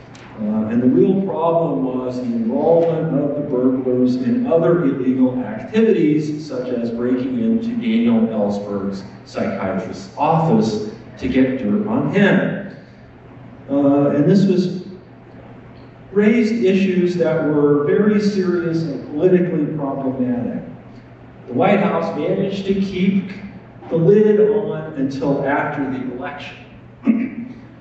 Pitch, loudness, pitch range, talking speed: 160 Hz, -18 LUFS, 130-195 Hz, 115 wpm